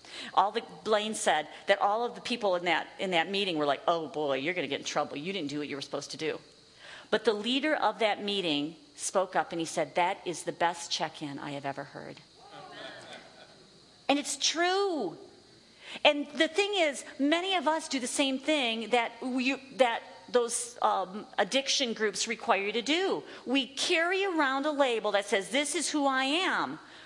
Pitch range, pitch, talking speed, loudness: 175-290 Hz, 235 Hz, 200 wpm, -29 LUFS